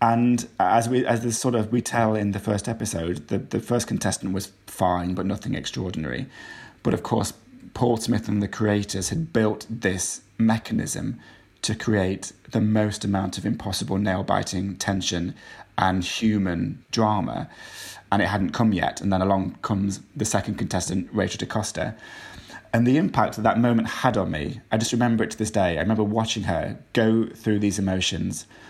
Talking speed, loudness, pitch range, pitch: 175 wpm, -24 LUFS, 95-115 Hz, 105 Hz